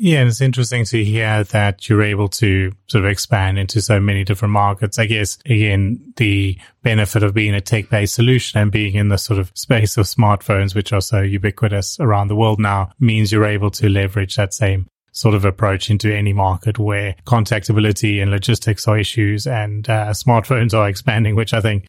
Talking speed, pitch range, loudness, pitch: 200 wpm, 100-110 Hz, -16 LUFS, 105 Hz